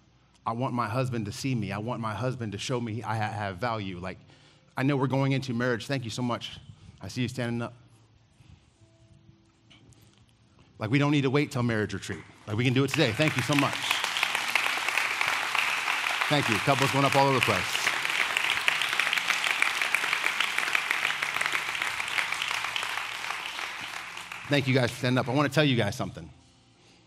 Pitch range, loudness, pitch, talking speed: 110-135 Hz, -27 LUFS, 120 Hz, 165 wpm